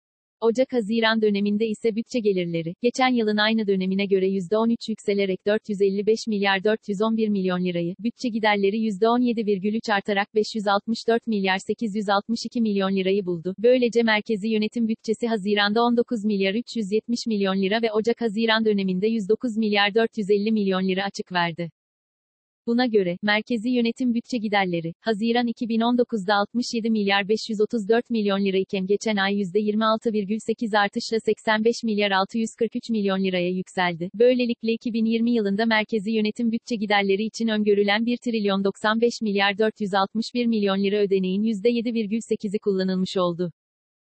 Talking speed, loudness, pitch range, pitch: 125 wpm, -23 LUFS, 200-230 Hz, 215 Hz